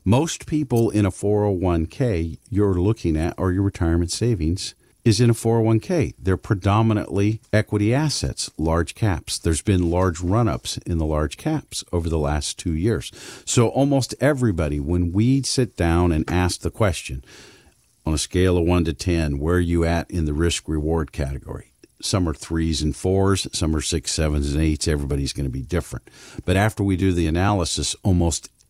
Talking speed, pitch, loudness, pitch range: 180 wpm, 90 Hz, -22 LUFS, 80-105 Hz